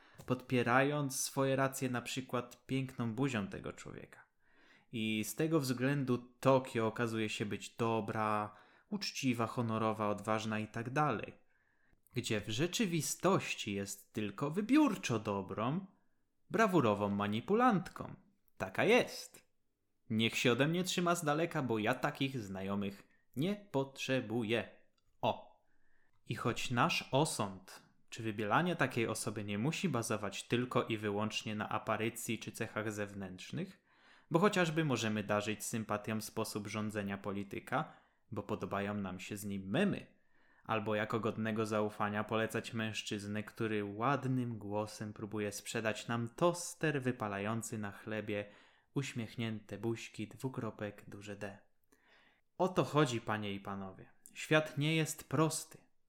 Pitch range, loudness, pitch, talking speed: 105-135 Hz, -36 LUFS, 115 Hz, 120 wpm